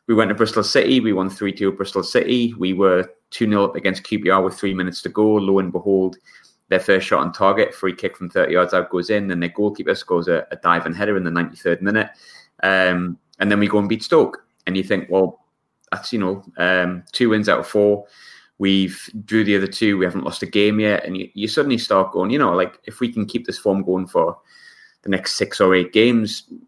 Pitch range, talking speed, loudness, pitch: 95-110 Hz, 235 wpm, -19 LUFS, 100 Hz